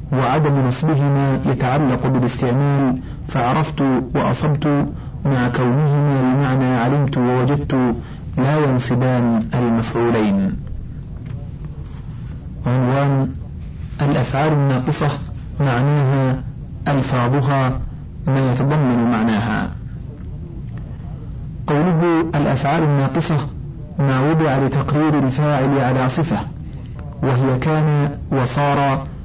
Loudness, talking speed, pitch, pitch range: -18 LUFS, 70 wpm, 135 Hz, 125-145 Hz